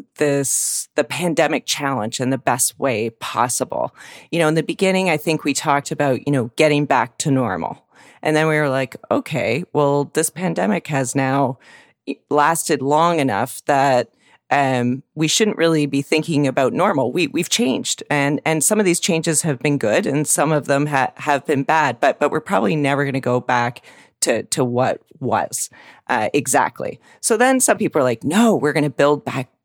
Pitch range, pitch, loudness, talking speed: 135-160 Hz, 145 Hz, -18 LUFS, 190 wpm